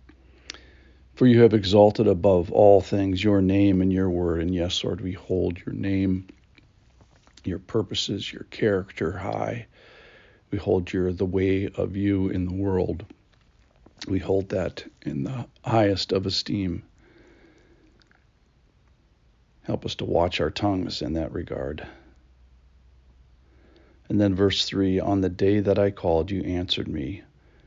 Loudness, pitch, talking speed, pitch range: -24 LUFS, 95 Hz, 140 wpm, 80-100 Hz